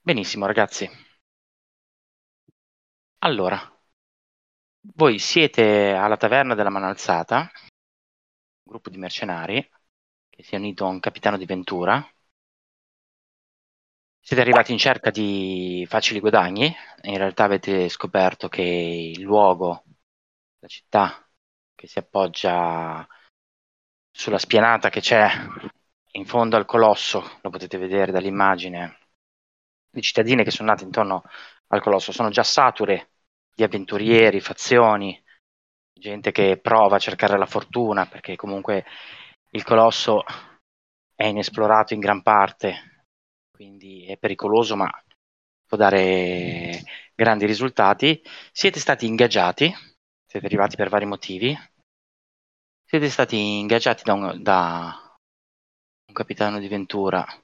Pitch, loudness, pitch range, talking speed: 100 Hz, -20 LUFS, 90-110 Hz, 115 wpm